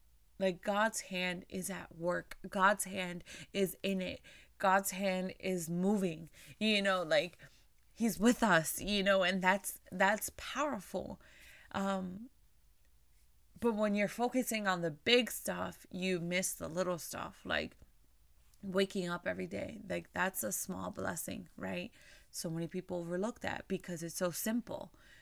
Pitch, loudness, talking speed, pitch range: 190 Hz, -35 LUFS, 145 wpm, 175-205 Hz